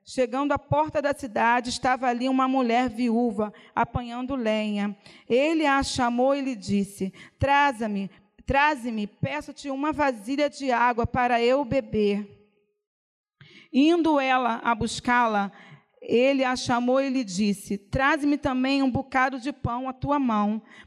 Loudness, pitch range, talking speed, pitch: -25 LUFS, 220-275 Hz, 130 wpm, 255 Hz